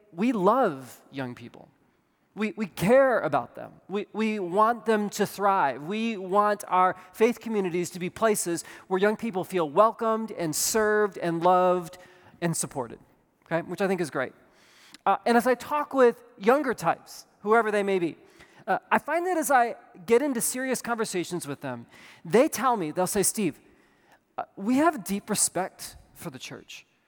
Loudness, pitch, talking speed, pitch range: -26 LUFS, 205 Hz, 170 wpm, 175-230 Hz